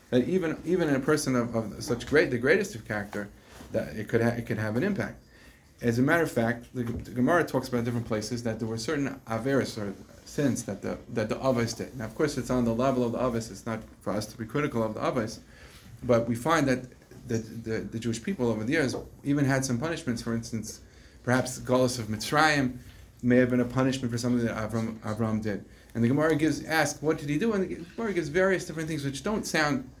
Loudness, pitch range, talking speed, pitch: -28 LUFS, 110-135 Hz, 240 wpm, 120 Hz